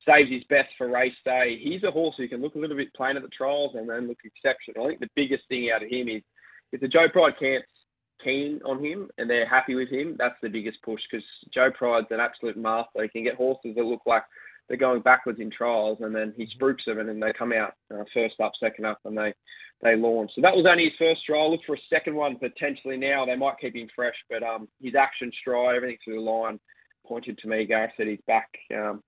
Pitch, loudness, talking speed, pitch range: 125 Hz, -25 LUFS, 250 wpm, 110-135 Hz